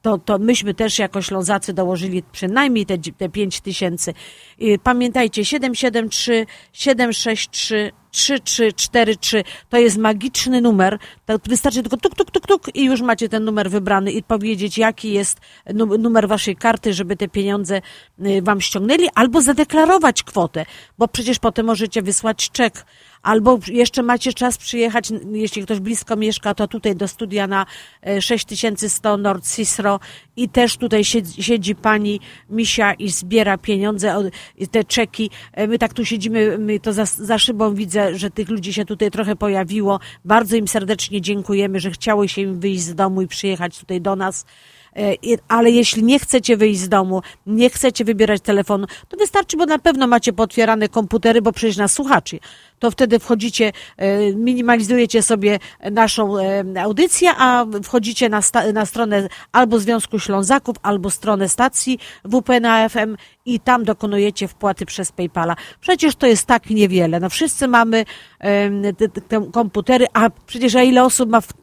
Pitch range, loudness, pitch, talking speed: 200-235 Hz, -17 LUFS, 220 Hz, 155 wpm